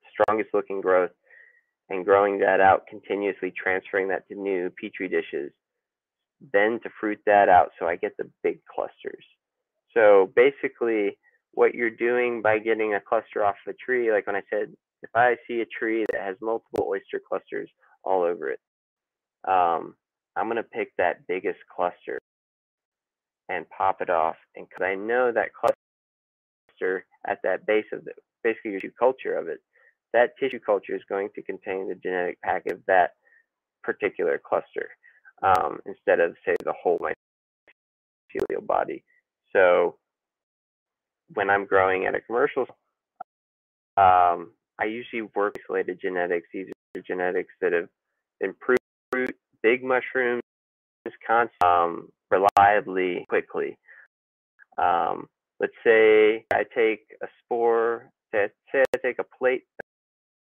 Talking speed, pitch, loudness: 140 wpm, 400 Hz, -25 LUFS